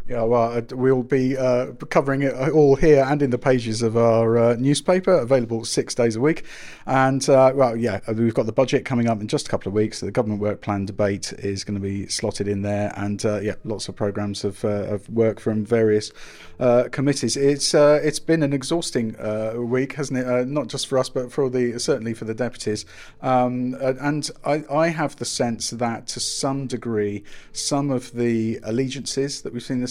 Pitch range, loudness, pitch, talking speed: 110-135 Hz, -22 LUFS, 125 Hz, 215 wpm